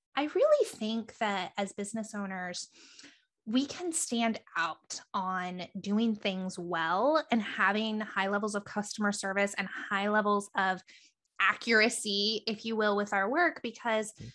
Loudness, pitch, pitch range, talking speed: -31 LUFS, 210 Hz, 195-230 Hz, 140 wpm